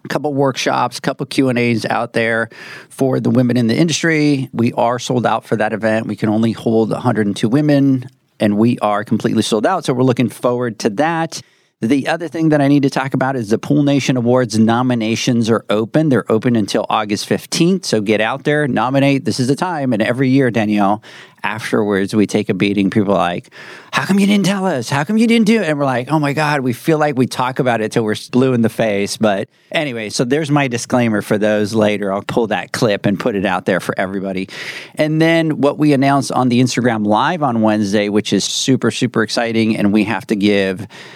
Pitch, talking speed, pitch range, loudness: 125 Hz, 225 wpm, 110-140 Hz, -16 LUFS